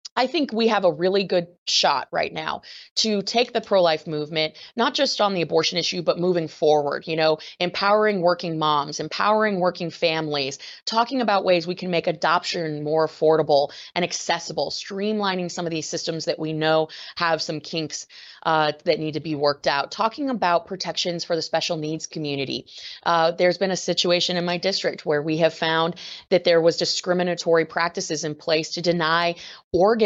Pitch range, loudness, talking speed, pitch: 160-185 Hz, -22 LUFS, 180 wpm, 170 Hz